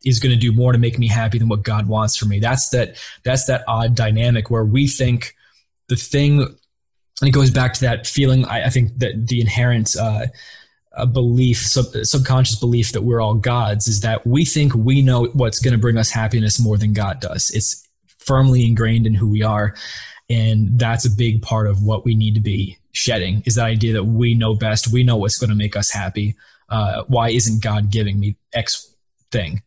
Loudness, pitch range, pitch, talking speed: -17 LUFS, 110-125 Hz, 115 Hz, 215 wpm